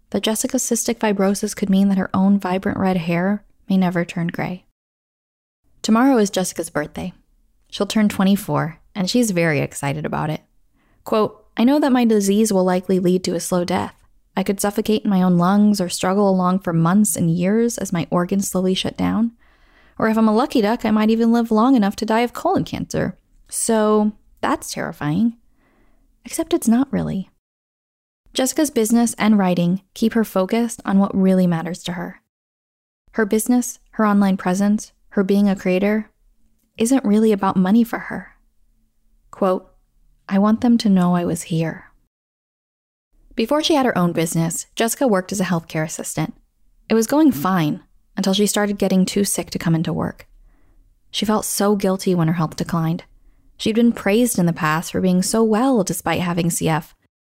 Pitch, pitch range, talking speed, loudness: 200 Hz, 180-225 Hz, 180 wpm, -19 LUFS